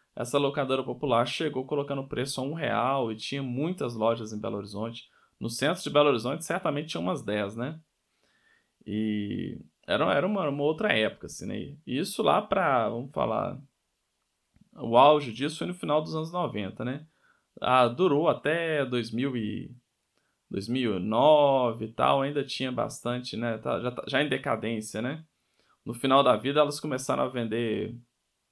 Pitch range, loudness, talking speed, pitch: 115-145 Hz, -28 LUFS, 165 wpm, 130 Hz